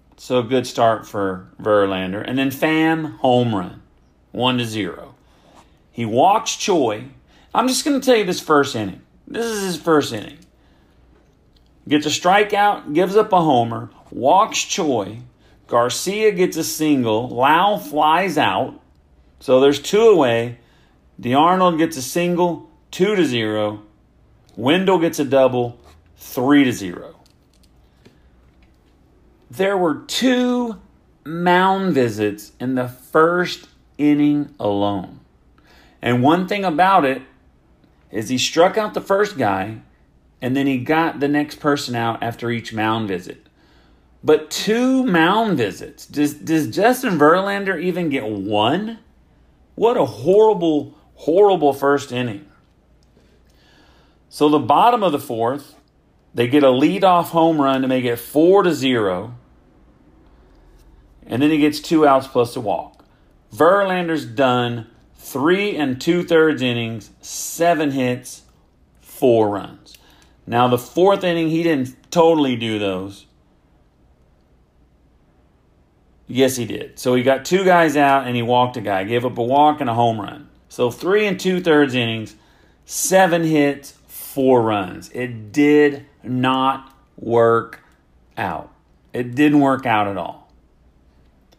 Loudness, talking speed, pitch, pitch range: -18 LUFS, 135 wpm, 130 Hz, 105-165 Hz